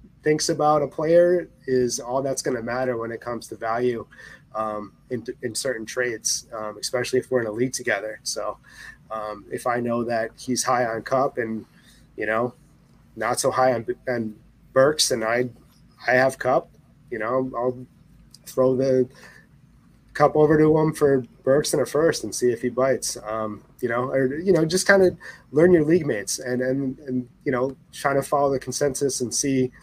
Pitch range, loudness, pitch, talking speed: 120-140 Hz, -23 LUFS, 130 Hz, 195 wpm